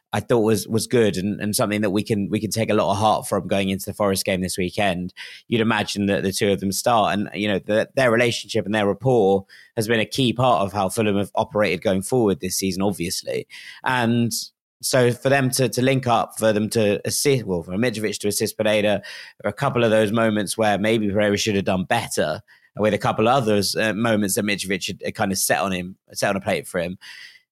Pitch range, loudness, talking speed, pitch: 100-115 Hz, -21 LUFS, 240 wpm, 105 Hz